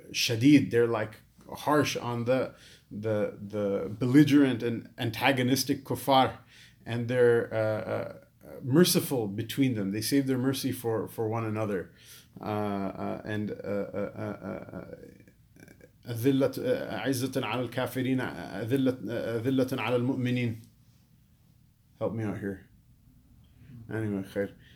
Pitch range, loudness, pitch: 110-130 Hz, -29 LUFS, 120 Hz